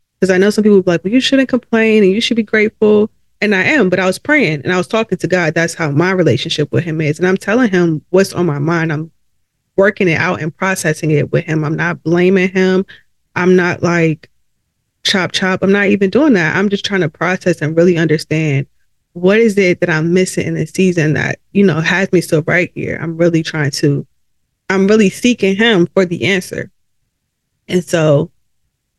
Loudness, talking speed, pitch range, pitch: -13 LUFS, 220 wpm, 160-195 Hz, 180 Hz